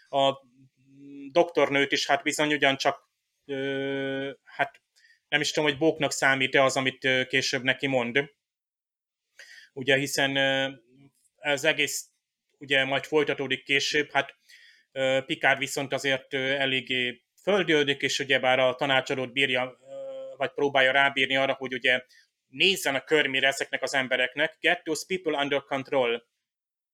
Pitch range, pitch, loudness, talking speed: 135-145 Hz, 140 Hz, -25 LUFS, 125 wpm